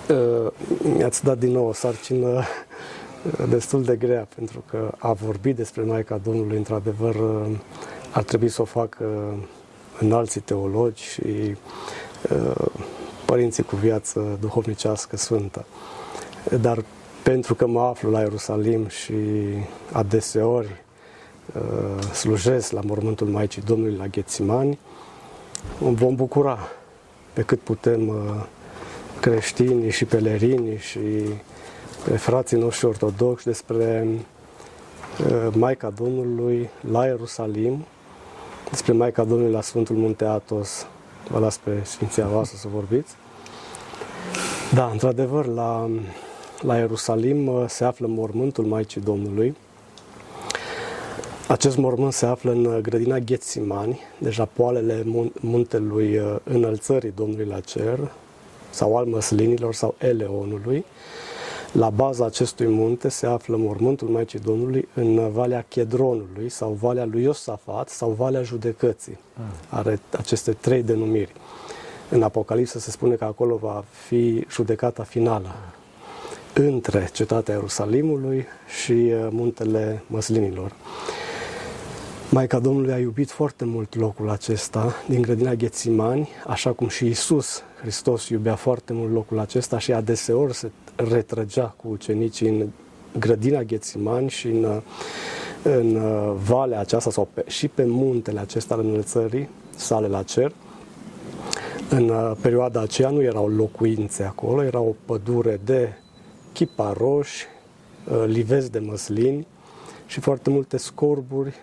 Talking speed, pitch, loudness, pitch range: 115 wpm, 115 Hz, -23 LUFS, 110-125 Hz